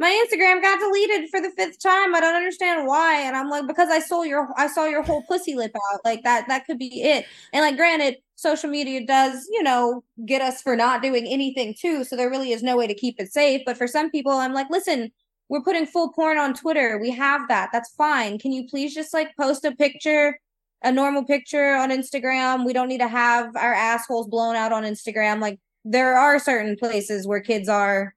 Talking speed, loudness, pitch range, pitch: 230 wpm, -21 LUFS, 240-305 Hz, 270 Hz